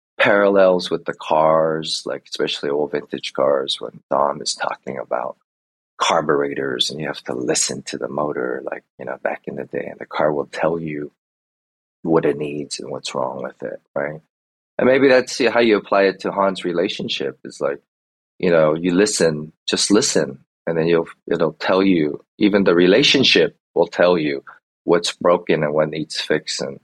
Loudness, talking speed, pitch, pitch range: -19 LUFS, 180 wpm, 80 Hz, 70-95 Hz